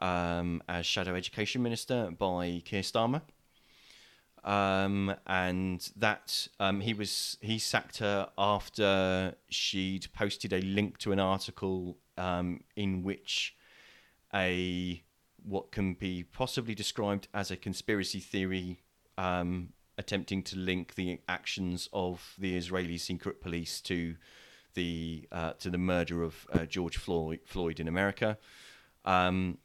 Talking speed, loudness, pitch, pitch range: 130 wpm, -33 LUFS, 95 Hz, 90-100 Hz